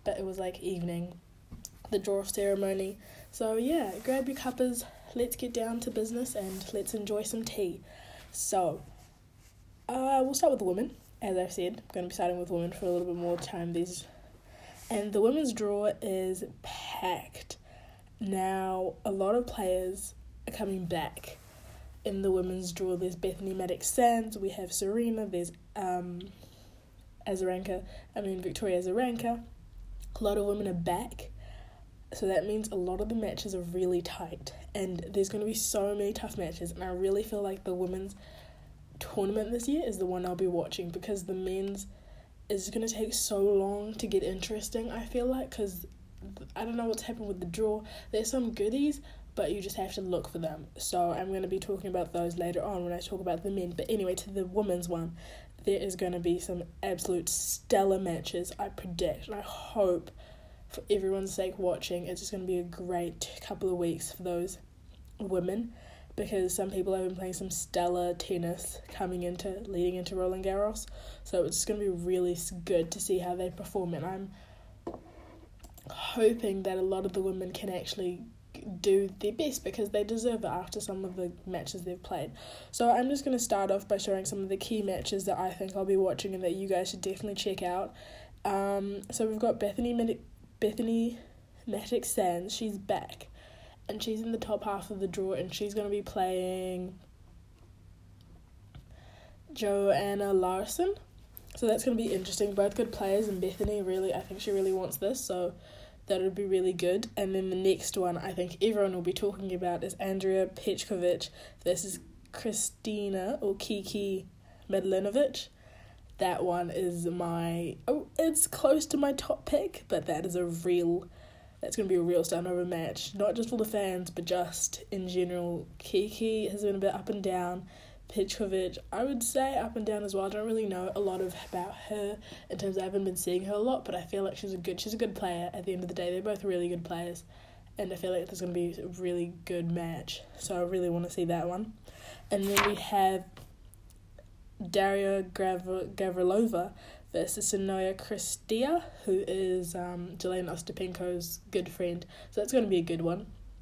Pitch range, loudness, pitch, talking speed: 180-210 Hz, -33 LUFS, 190 Hz, 195 wpm